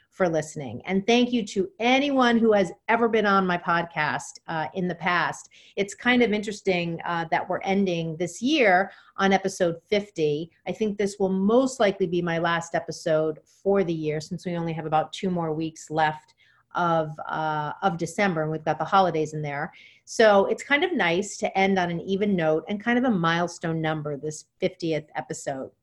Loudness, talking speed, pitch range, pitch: -25 LUFS, 195 wpm, 160-200 Hz, 175 Hz